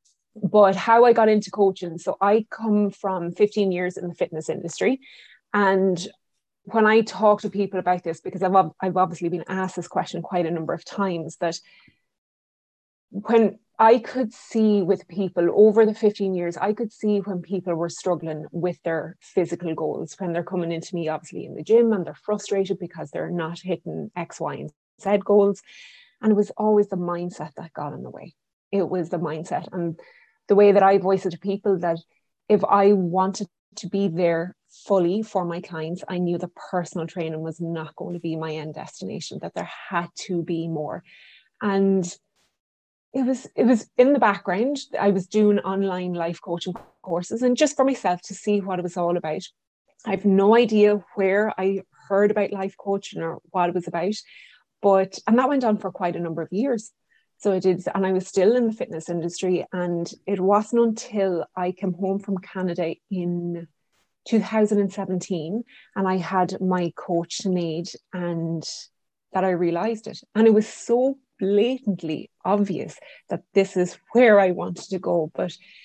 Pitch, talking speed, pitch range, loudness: 190 Hz, 185 wpm, 175-210 Hz, -23 LUFS